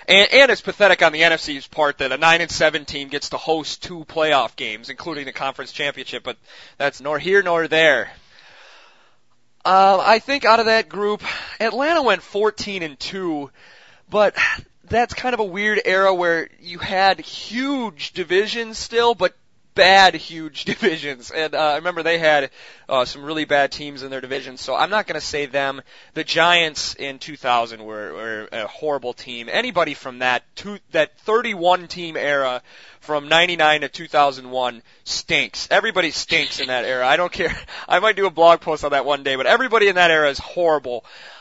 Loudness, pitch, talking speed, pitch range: -18 LUFS, 160 Hz, 185 wpm, 140-195 Hz